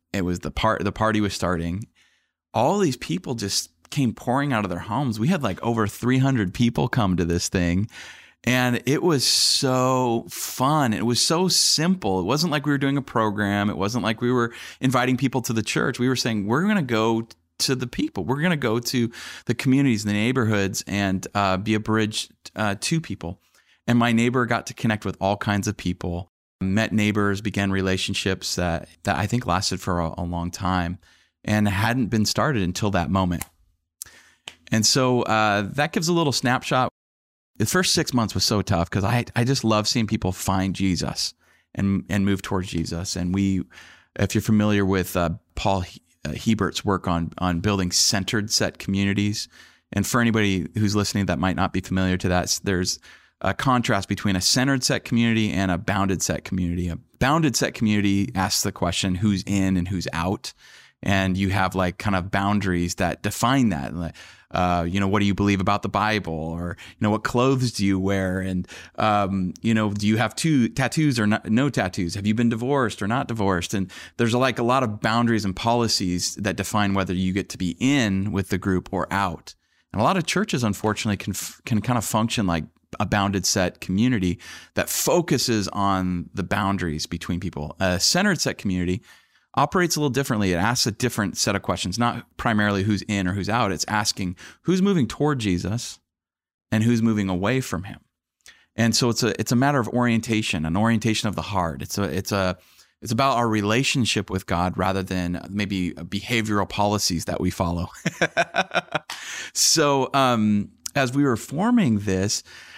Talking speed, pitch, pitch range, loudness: 195 wpm, 105 Hz, 95-120 Hz, -23 LUFS